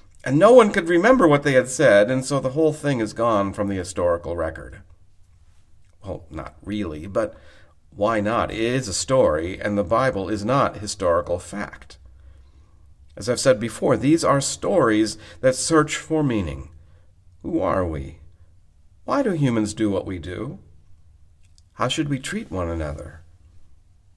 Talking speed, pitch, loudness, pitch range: 160 wpm, 95 Hz, -21 LUFS, 85-115 Hz